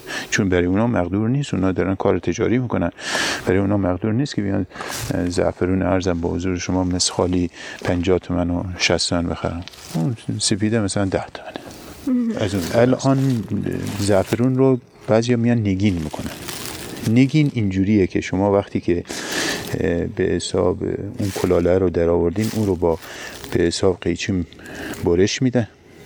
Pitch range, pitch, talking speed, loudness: 90-115 Hz, 100 Hz, 145 wpm, -20 LUFS